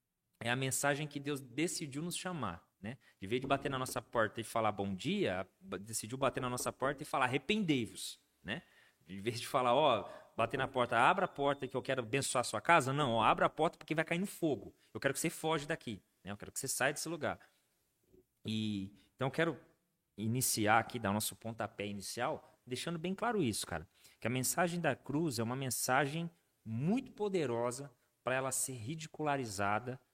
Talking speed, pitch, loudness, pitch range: 200 wpm, 130 Hz, -36 LUFS, 115-155 Hz